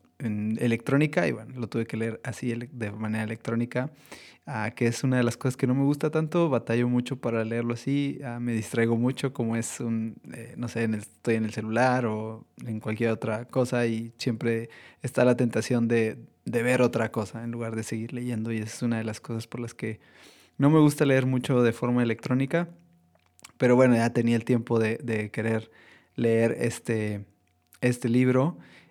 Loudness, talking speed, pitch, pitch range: -27 LUFS, 185 wpm, 115 Hz, 115-125 Hz